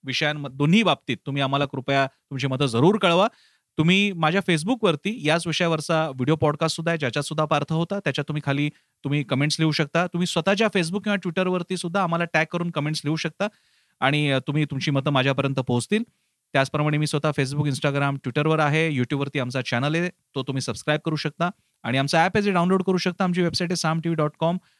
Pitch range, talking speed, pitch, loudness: 140-175 Hz, 190 wpm, 155 Hz, -23 LUFS